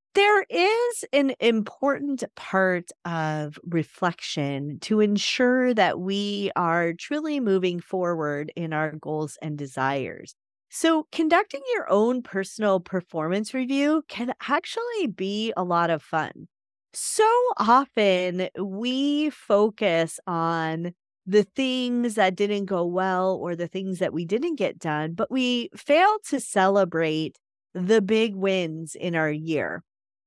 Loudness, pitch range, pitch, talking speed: -24 LUFS, 170-255 Hz, 195 Hz, 125 wpm